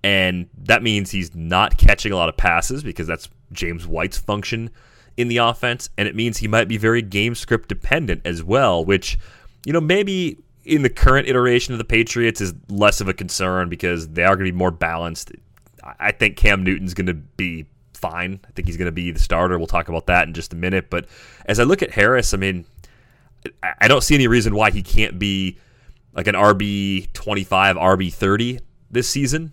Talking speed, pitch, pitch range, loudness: 205 wpm, 95 Hz, 90-115 Hz, -19 LUFS